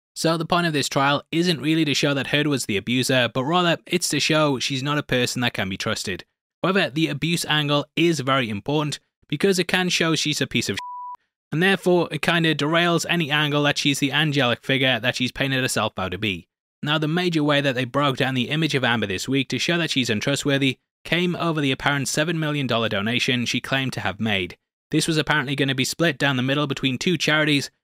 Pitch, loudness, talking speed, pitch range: 145 Hz, -21 LUFS, 235 wpm, 130-160 Hz